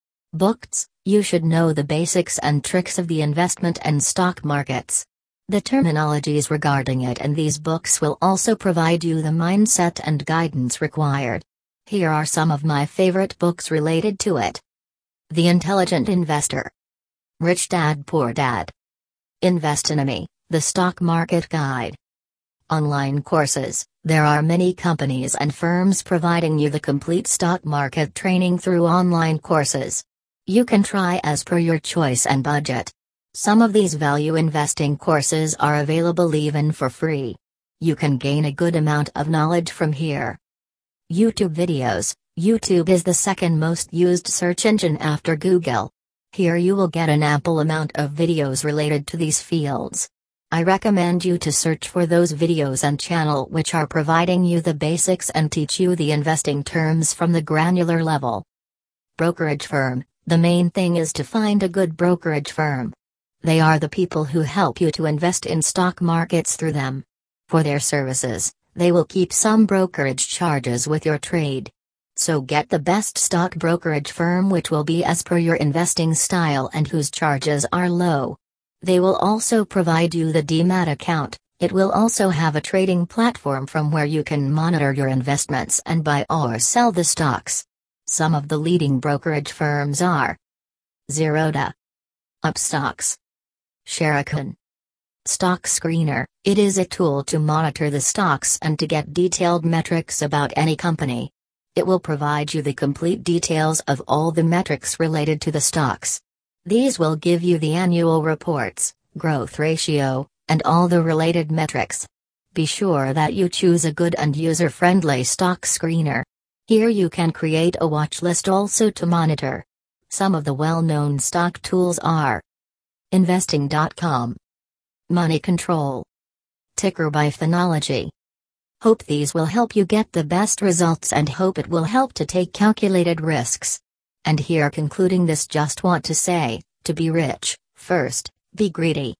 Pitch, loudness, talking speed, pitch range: 160 Hz, -20 LUFS, 155 wpm, 145-175 Hz